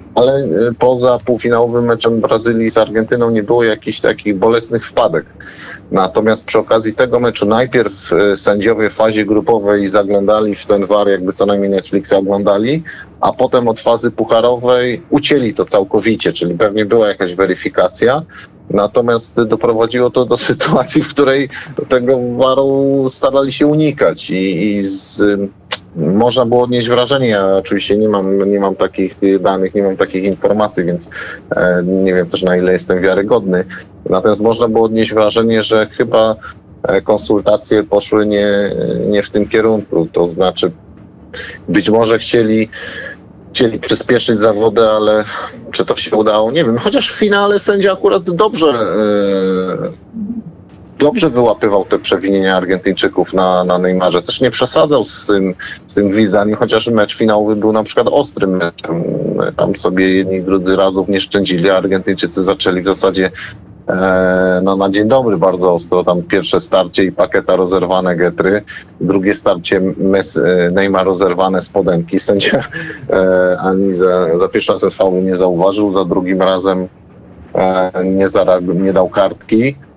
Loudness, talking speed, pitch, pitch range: -13 LUFS, 145 wpm, 105 Hz, 95-115 Hz